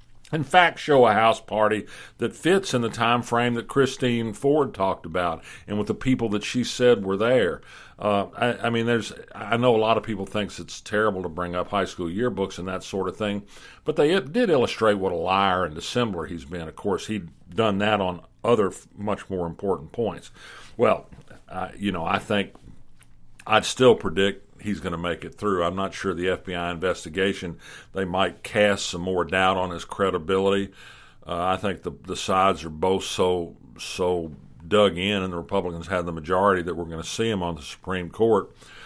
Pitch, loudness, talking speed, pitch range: 95 Hz, -24 LUFS, 200 wpm, 90-110 Hz